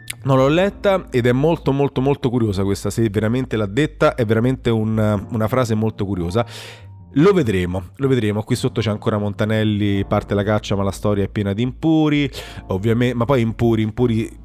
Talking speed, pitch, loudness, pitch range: 185 wpm, 115 Hz, -19 LUFS, 105-130 Hz